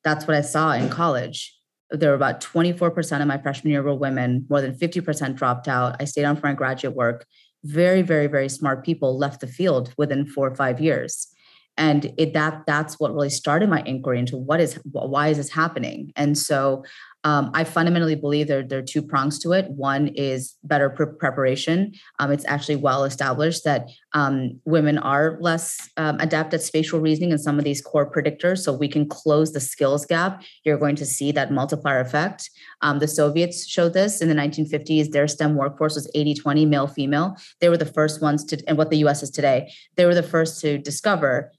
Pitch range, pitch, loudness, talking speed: 140-160 Hz, 150 Hz, -22 LUFS, 210 wpm